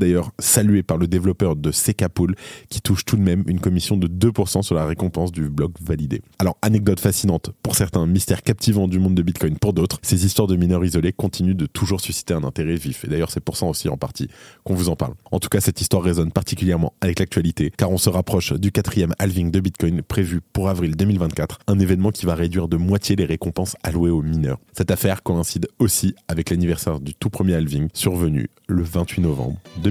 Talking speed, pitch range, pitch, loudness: 215 wpm, 85-100 Hz, 95 Hz, -20 LUFS